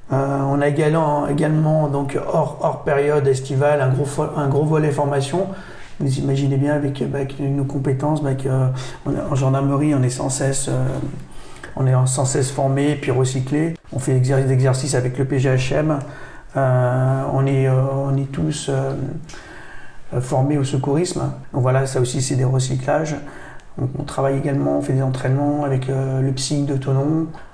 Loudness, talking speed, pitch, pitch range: -20 LUFS, 160 wpm, 140 Hz, 130-145 Hz